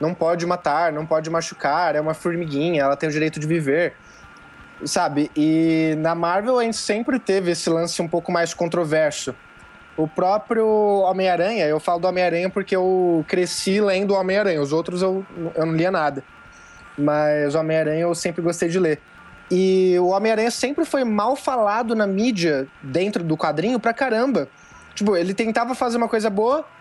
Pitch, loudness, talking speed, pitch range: 180 Hz, -21 LUFS, 175 wpm, 160-210 Hz